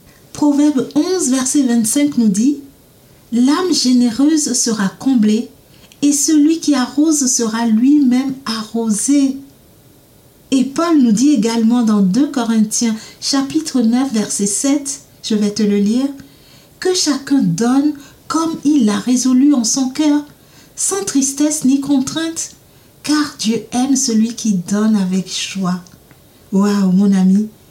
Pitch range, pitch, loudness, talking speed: 220-290 Hz, 255 Hz, -15 LUFS, 130 wpm